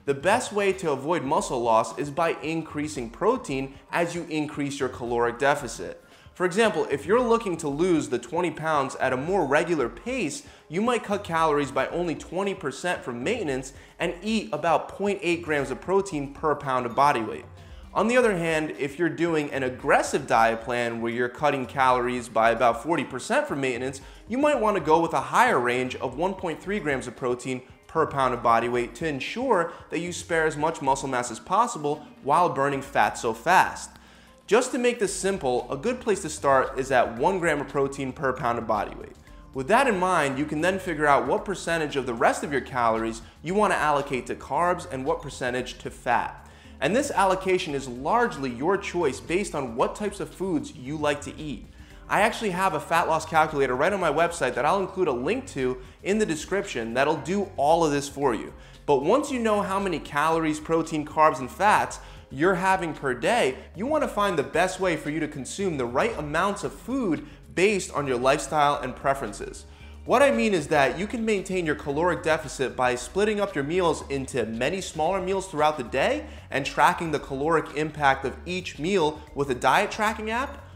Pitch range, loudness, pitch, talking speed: 135-185 Hz, -25 LUFS, 155 Hz, 205 wpm